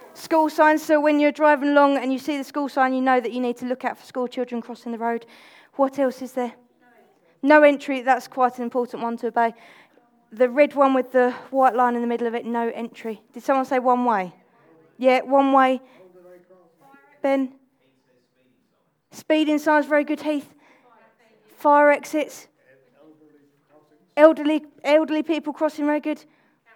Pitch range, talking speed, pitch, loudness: 235-290 Hz, 170 wpm, 260 Hz, -21 LUFS